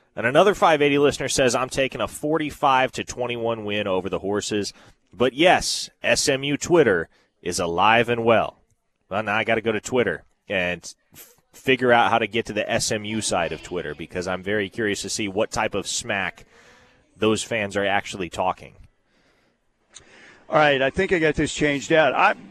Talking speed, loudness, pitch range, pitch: 185 wpm, -22 LUFS, 105-140 Hz, 115 Hz